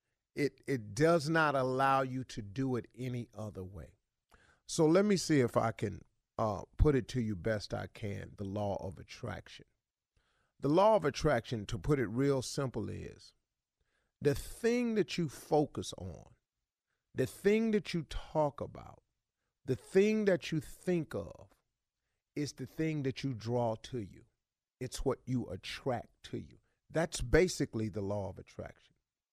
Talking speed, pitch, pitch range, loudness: 160 wpm, 130 Hz, 110-155 Hz, -34 LUFS